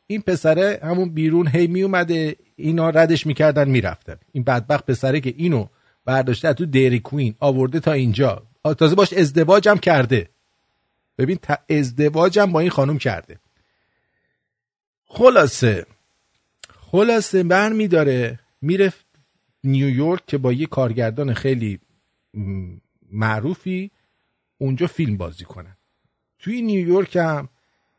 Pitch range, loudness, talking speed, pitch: 120-175 Hz, -19 LUFS, 110 wpm, 145 Hz